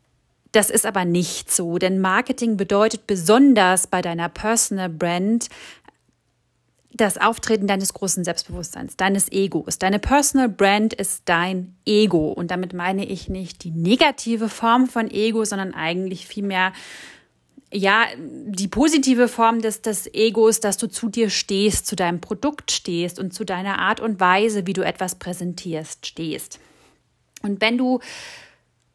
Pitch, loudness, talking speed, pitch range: 200 Hz, -20 LUFS, 145 wpm, 185-225 Hz